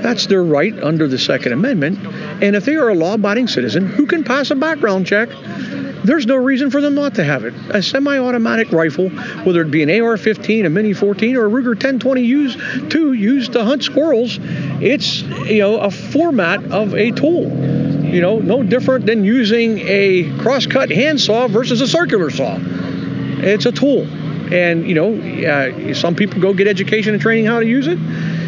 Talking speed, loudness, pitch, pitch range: 185 wpm, -15 LUFS, 215 Hz, 180-255 Hz